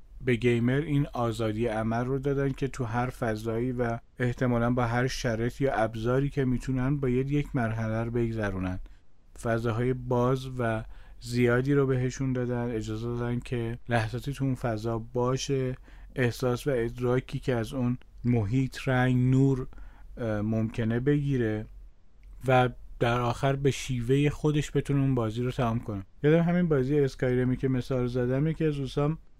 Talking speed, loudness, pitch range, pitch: 150 wpm, -28 LUFS, 115-135 Hz, 125 Hz